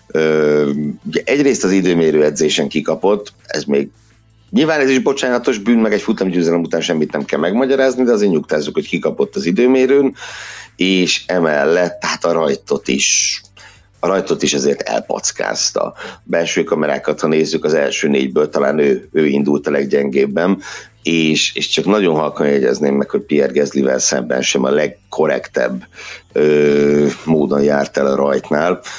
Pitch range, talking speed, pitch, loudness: 75-105 Hz, 150 wpm, 80 Hz, -15 LUFS